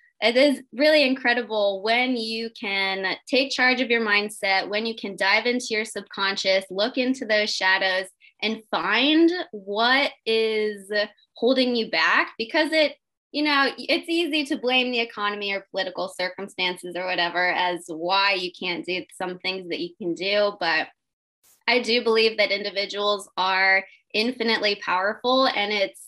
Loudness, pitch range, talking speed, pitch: -22 LUFS, 190-245 Hz, 155 wpm, 210 Hz